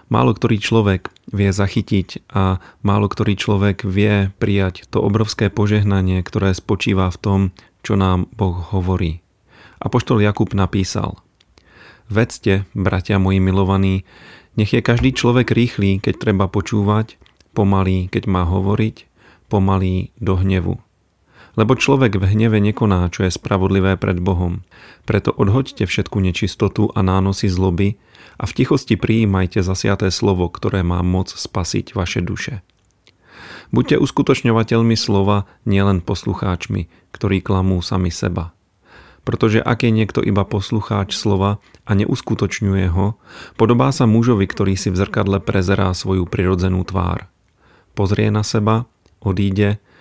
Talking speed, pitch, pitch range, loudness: 130 wpm, 100 Hz, 95-110 Hz, -18 LUFS